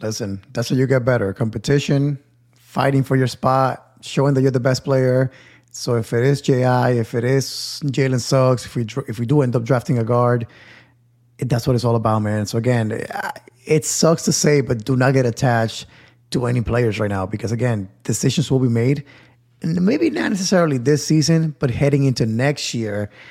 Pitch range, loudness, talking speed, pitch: 120-140 Hz, -19 LUFS, 200 wpm, 130 Hz